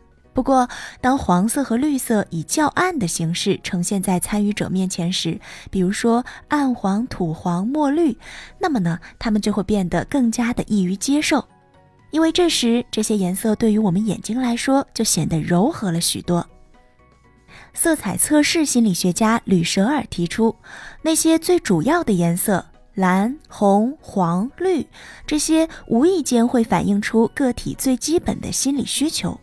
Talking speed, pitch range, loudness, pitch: 235 characters per minute, 185-275 Hz, -19 LUFS, 225 Hz